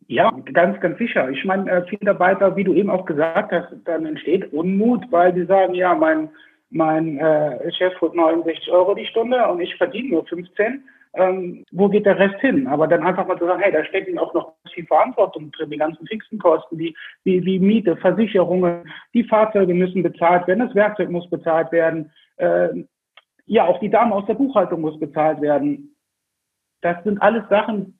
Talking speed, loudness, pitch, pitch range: 190 wpm, -19 LUFS, 180 Hz, 165-200 Hz